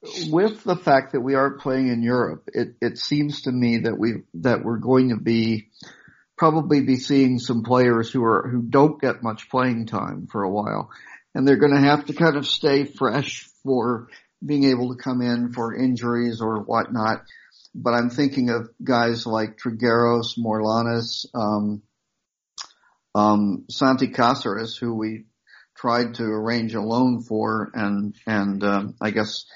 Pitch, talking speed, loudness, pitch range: 120 Hz, 165 wpm, -22 LUFS, 110-130 Hz